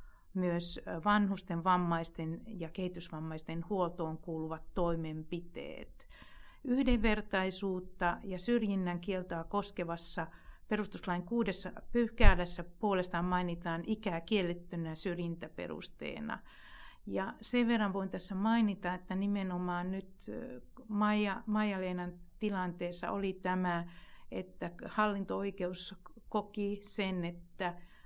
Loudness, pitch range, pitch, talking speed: -36 LUFS, 175-205 Hz, 185 Hz, 85 wpm